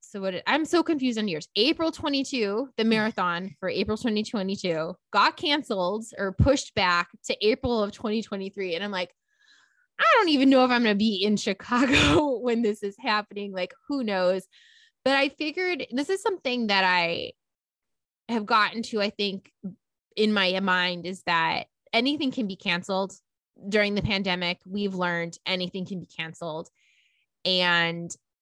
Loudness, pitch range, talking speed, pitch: -25 LUFS, 185-255 Hz, 165 wpm, 210 Hz